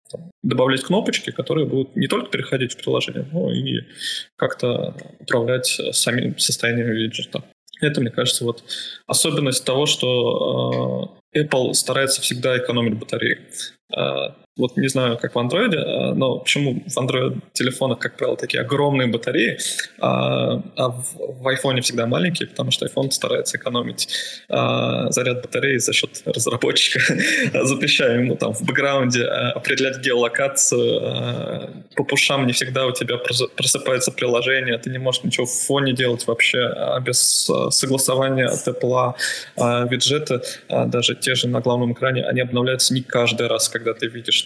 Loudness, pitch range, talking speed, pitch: -20 LUFS, 120-135 Hz, 135 wpm, 125 Hz